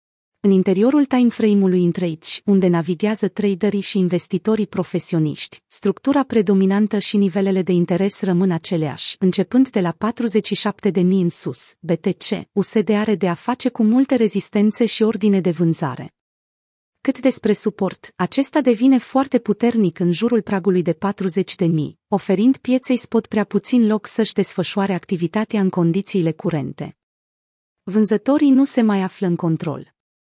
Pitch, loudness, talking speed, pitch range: 200 Hz, -19 LUFS, 135 wpm, 180-220 Hz